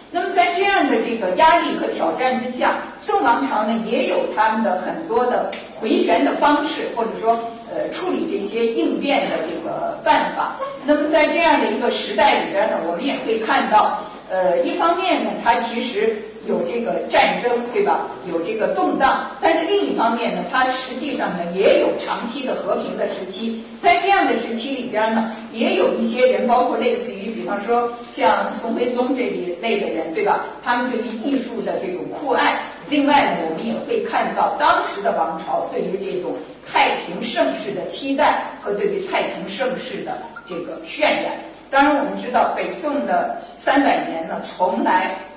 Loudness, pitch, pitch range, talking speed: -20 LUFS, 255 Hz, 230-310 Hz, 270 characters per minute